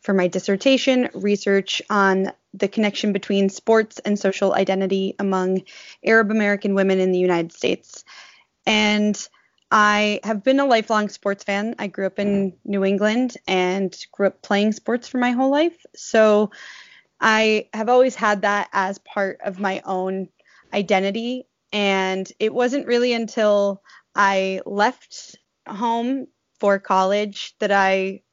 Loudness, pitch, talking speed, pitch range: -20 LUFS, 205 Hz, 140 wpm, 195-225 Hz